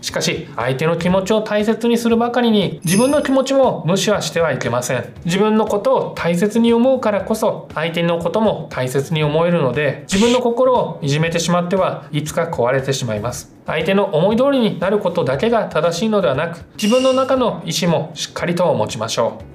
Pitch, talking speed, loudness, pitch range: 185 Hz, 410 characters per minute, -17 LUFS, 160-225 Hz